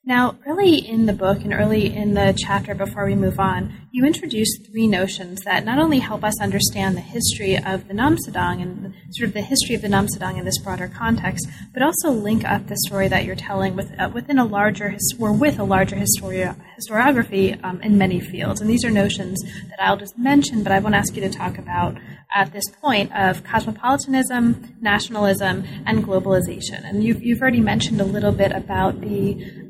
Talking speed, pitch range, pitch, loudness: 195 wpm, 190-230 Hz, 205 Hz, -20 LUFS